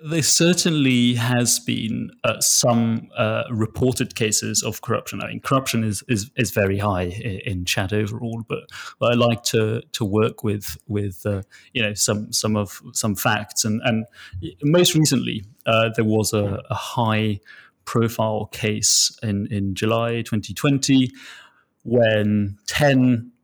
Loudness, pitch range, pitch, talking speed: -21 LUFS, 105-120 Hz, 115 Hz, 145 wpm